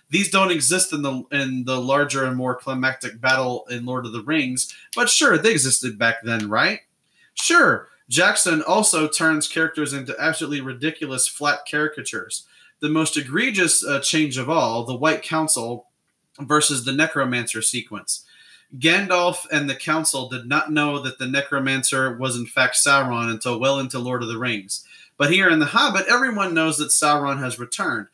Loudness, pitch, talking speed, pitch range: -20 LUFS, 140 Hz, 170 wpm, 130-155 Hz